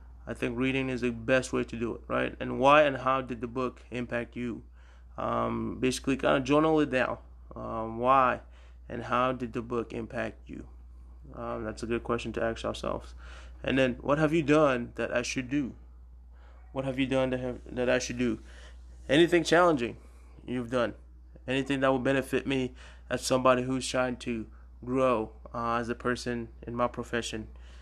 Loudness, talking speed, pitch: -29 LUFS, 185 wpm, 120 Hz